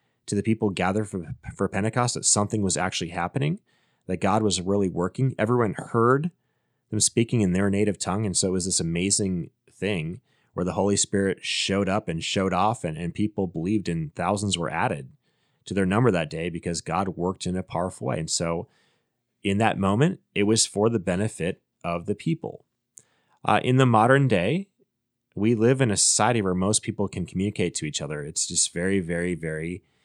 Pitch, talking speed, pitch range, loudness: 100 Hz, 195 wpm, 90-110 Hz, -24 LUFS